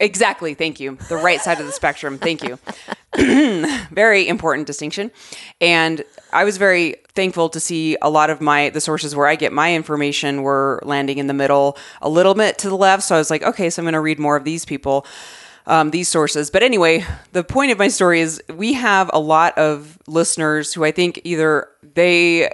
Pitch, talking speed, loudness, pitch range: 160 Hz, 210 wpm, -17 LUFS, 150-180 Hz